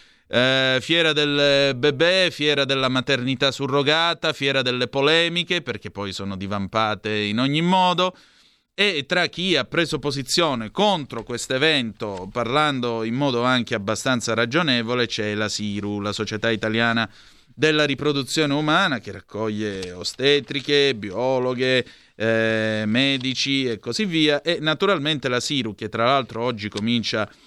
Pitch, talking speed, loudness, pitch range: 130 Hz, 130 wpm, -21 LUFS, 110-150 Hz